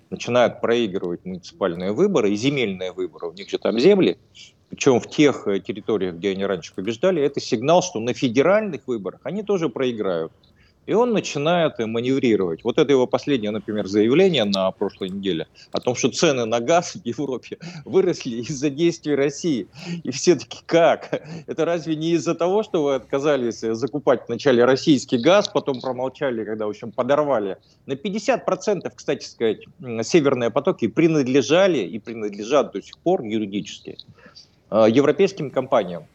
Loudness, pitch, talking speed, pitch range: -21 LUFS, 130 Hz, 150 wpm, 115-160 Hz